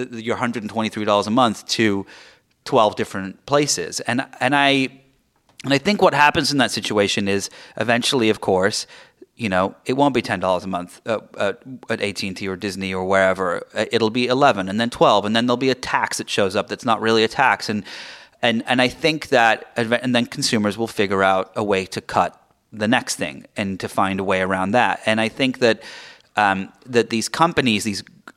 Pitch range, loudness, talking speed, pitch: 100-130 Hz, -20 LUFS, 210 wpm, 115 Hz